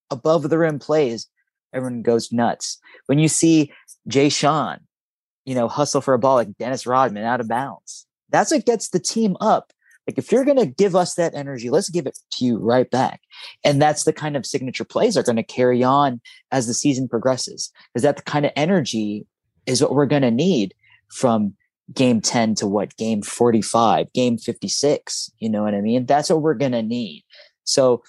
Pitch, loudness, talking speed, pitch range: 135 Hz, -20 LUFS, 205 wpm, 120-155 Hz